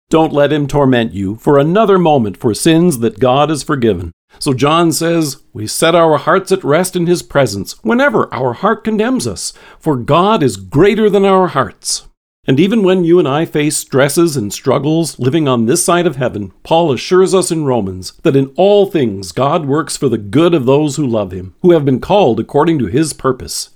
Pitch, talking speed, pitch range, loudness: 150 Hz, 205 wpm, 125-175 Hz, -13 LUFS